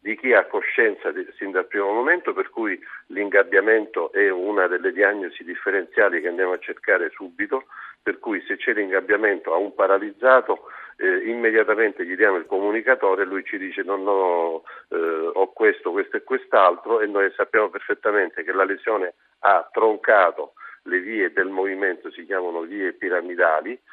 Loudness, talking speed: -21 LUFS, 165 wpm